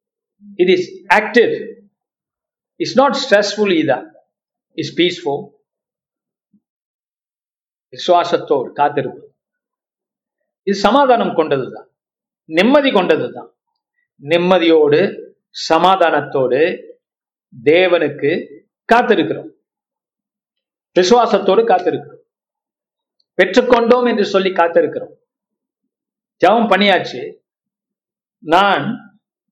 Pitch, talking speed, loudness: 230 Hz, 45 wpm, -14 LUFS